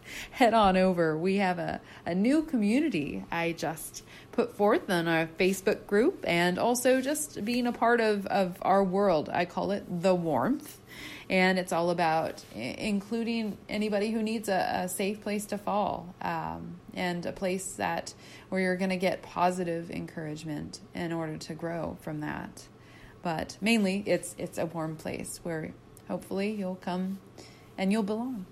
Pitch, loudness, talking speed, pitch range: 190 Hz, -29 LUFS, 165 wpm, 175-215 Hz